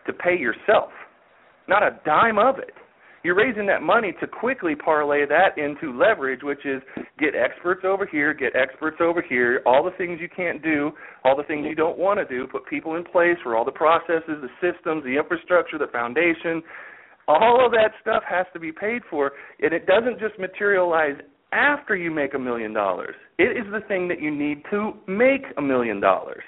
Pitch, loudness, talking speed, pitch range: 165 Hz, -22 LUFS, 200 wpm, 145-200 Hz